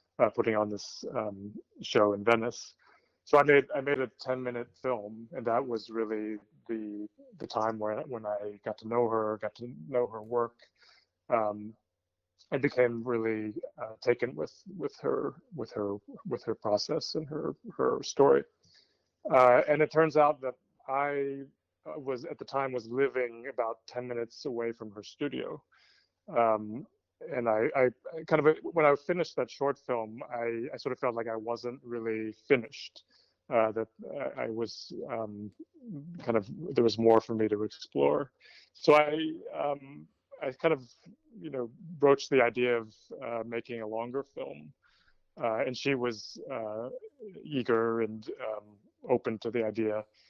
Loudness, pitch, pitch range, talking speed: -31 LUFS, 115 Hz, 110-135 Hz, 165 wpm